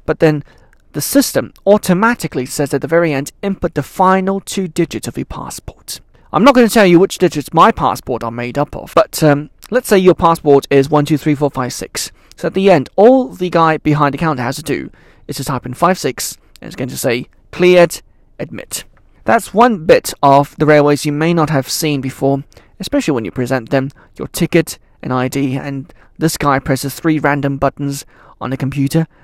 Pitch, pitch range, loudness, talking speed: 150 Hz, 135-180 Hz, -14 LUFS, 210 wpm